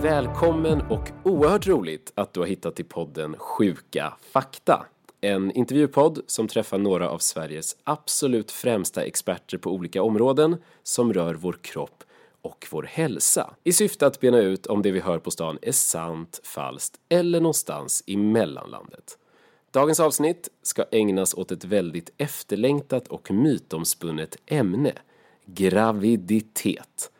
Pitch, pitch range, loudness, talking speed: 115 Hz, 95-155 Hz, -24 LUFS, 135 wpm